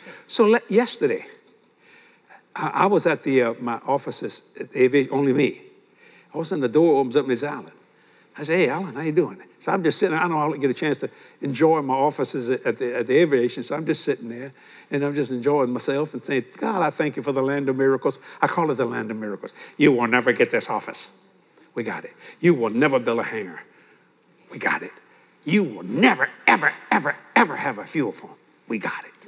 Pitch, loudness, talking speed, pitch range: 140 Hz, -22 LUFS, 225 wpm, 125-160 Hz